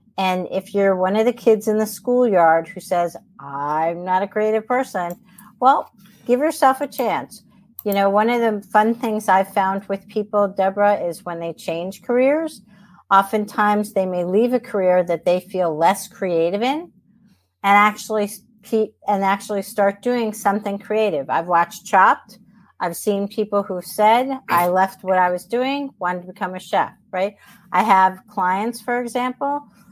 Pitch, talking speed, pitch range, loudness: 205 Hz, 170 wpm, 185-220 Hz, -20 LUFS